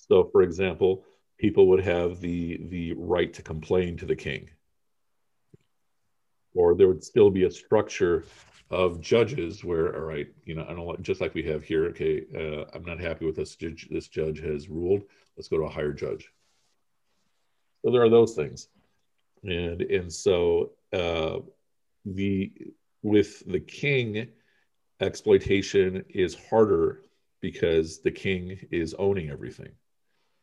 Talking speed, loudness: 145 wpm, -26 LUFS